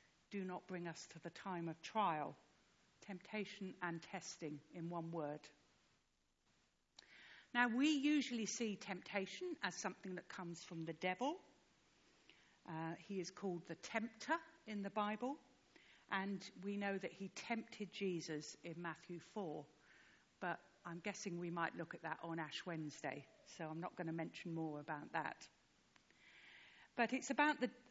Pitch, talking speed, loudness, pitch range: 185 Hz, 150 wpm, -45 LUFS, 165-210 Hz